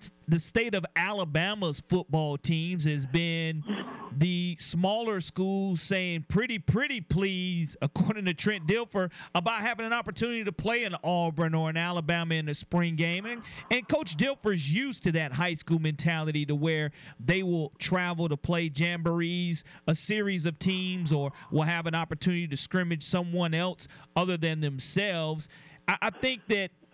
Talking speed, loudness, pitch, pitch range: 160 wpm, -29 LUFS, 175 Hz, 160-195 Hz